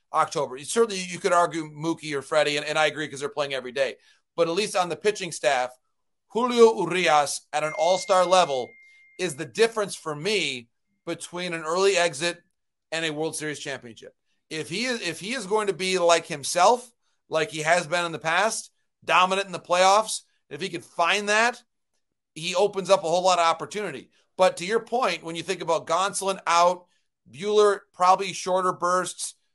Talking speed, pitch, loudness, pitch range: 190 wpm, 175 Hz, -24 LUFS, 160-200 Hz